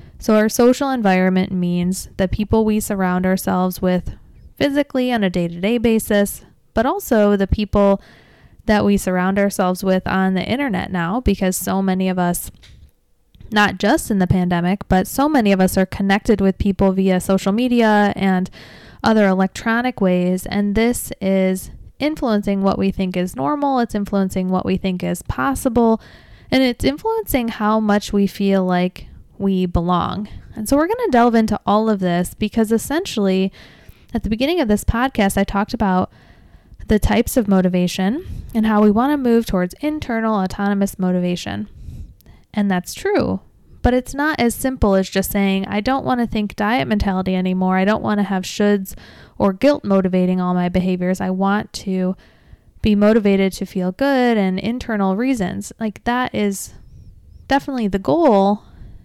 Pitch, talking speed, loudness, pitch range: 200 Hz, 170 wpm, -18 LUFS, 185-225 Hz